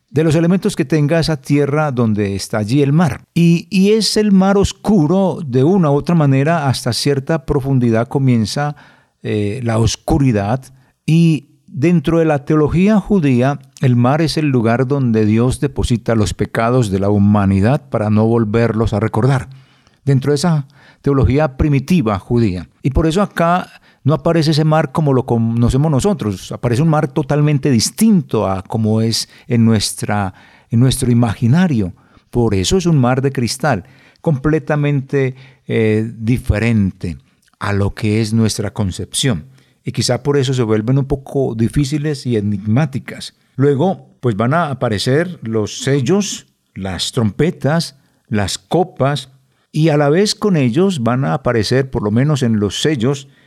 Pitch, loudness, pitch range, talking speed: 135 Hz, -15 LUFS, 115-155 Hz, 155 wpm